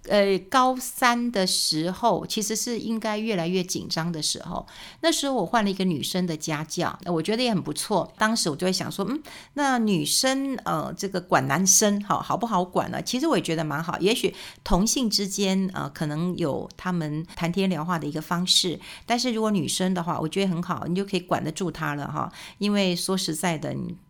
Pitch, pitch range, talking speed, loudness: 185 Hz, 170-215 Hz, 305 characters per minute, -25 LUFS